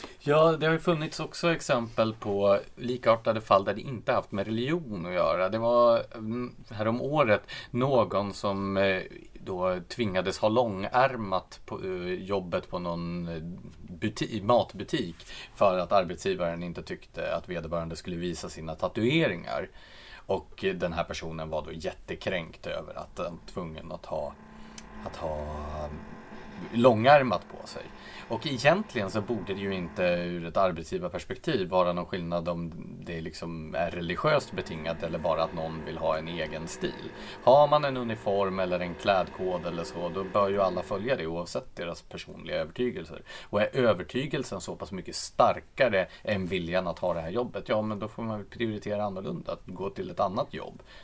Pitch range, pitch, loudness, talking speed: 85-115 Hz, 100 Hz, -29 LUFS, 160 wpm